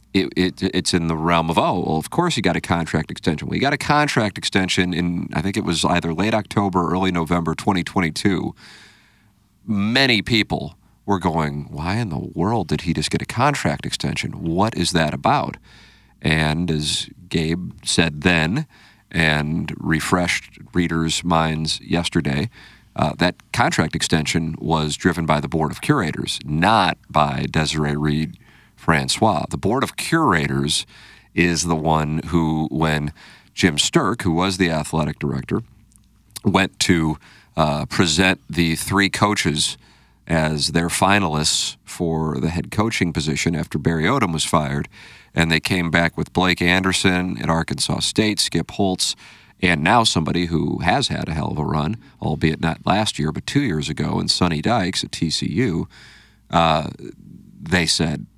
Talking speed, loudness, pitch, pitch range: 160 wpm, -20 LUFS, 85 Hz, 80-95 Hz